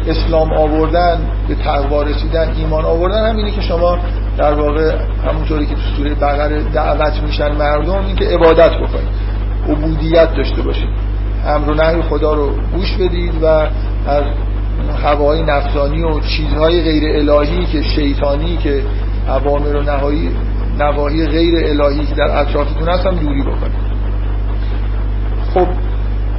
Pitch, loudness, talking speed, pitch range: 140 Hz, -15 LUFS, 135 wpm, 100-150 Hz